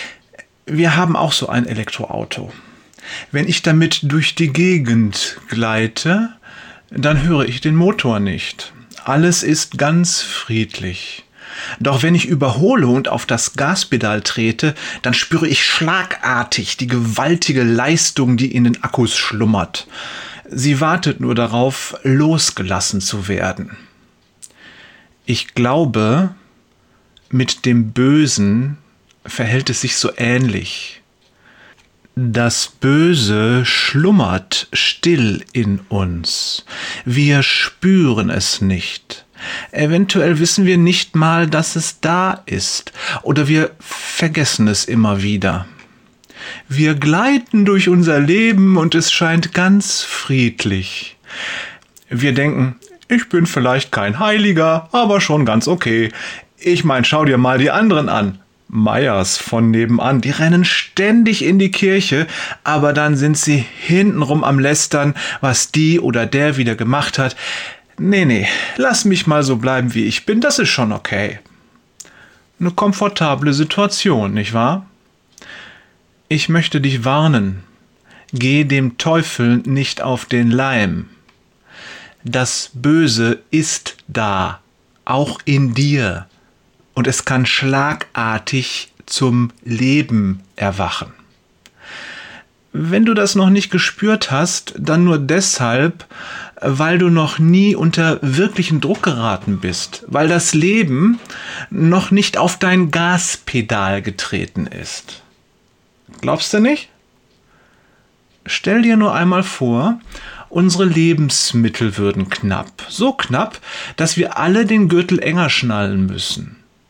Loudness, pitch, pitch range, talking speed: -15 LUFS, 145 Hz, 120-175 Hz, 120 wpm